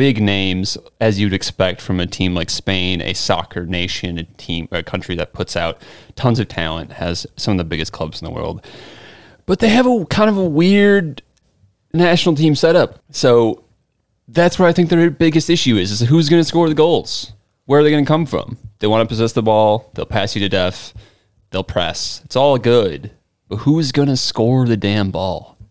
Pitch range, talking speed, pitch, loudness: 95-150 Hz, 210 wpm, 110 Hz, -16 LUFS